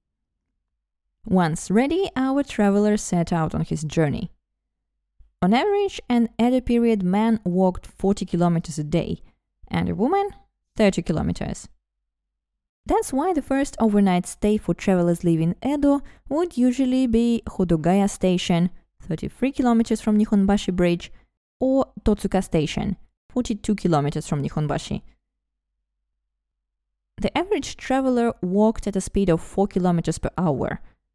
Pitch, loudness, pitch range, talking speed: 190 Hz, -22 LUFS, 155-230 Hz, 125 wpm